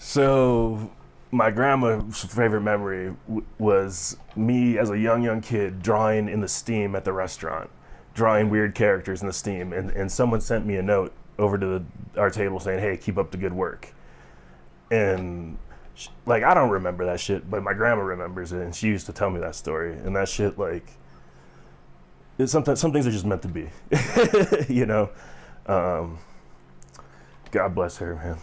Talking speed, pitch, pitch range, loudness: 180 wpm, 95 Hz, 85-110 Hz, -24 LUFS